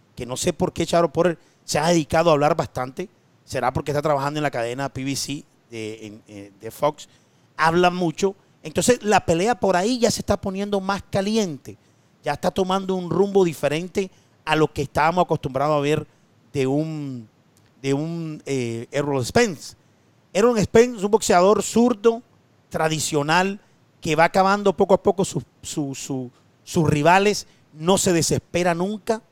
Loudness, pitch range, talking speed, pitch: -21 LUFS, 135-190 Hz, 160 wpm, 160 Hz